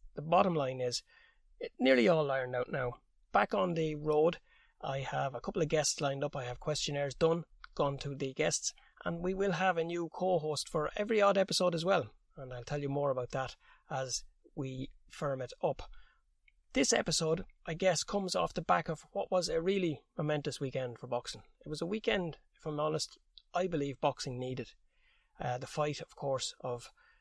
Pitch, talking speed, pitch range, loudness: 150 Hz, 195 wpm, 135-175 Hz, -34 LUFS